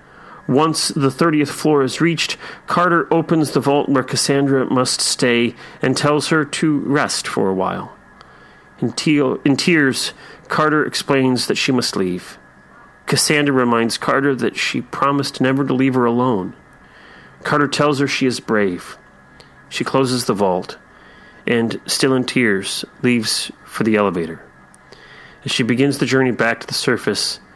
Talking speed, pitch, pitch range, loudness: 150 wpm, 135 Hz, 120-145 Hz, -17 LUFS